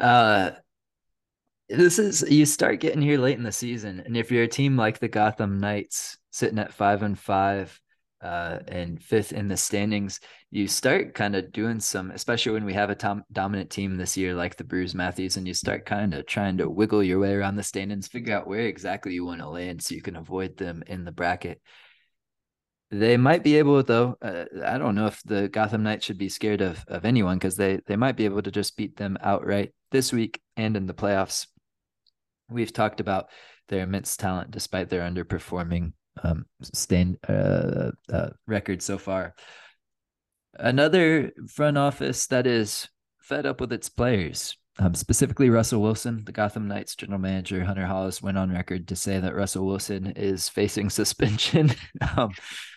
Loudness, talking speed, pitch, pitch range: -25 LUFS, 190 wpm, 100 Hz, 95-115 Hz